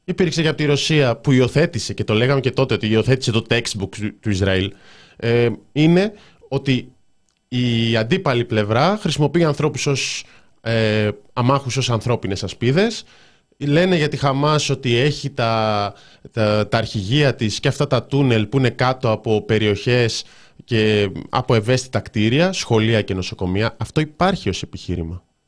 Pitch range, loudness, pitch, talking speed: 110-145 Hz, -19 LUFS, 120 Hz, 150 wpm